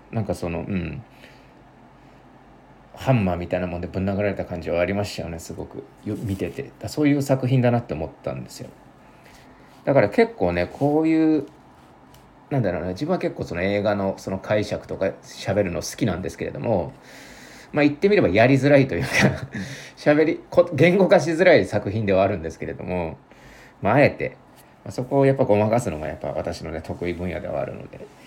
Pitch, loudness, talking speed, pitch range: 105 Hz, -22 LUFS, 365 characters per minute, 85-140 Hz